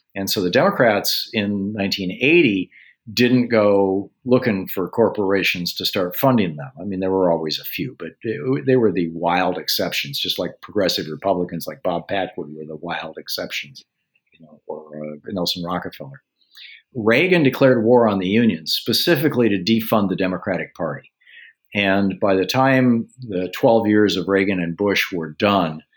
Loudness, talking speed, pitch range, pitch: -19 LUFS, 160 wpm, 90-115 Hz, 100 Hz